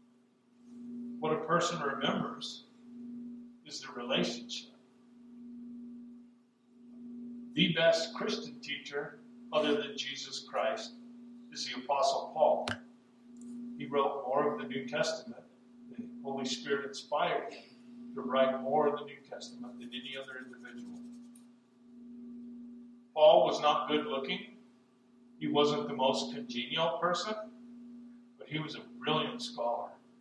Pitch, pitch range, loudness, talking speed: 240 Hz, 180-240 Hz, -33 LUFS, 115 wpm